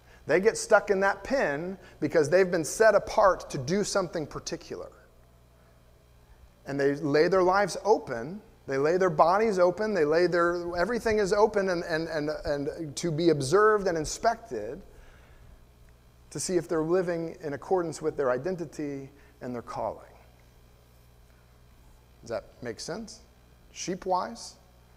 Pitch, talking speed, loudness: 155 Hz, 140 wpm, -27 LUFS